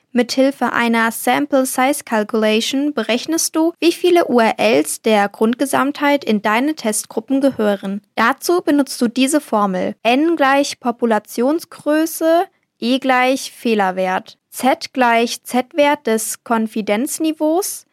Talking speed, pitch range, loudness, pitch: 110 wpm, 225-290 Hz, -17 LUFS, 255 Hz